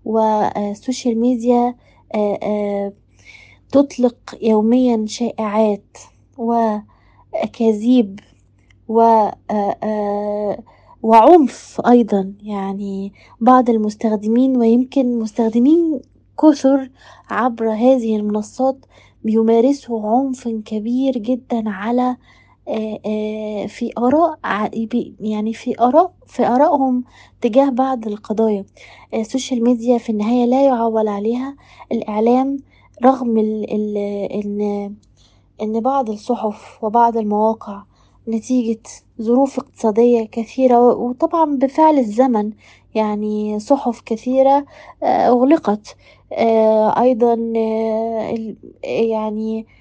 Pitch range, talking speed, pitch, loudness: 215-255 Hz, 75 wpm, 230 Hz, -17 LUFS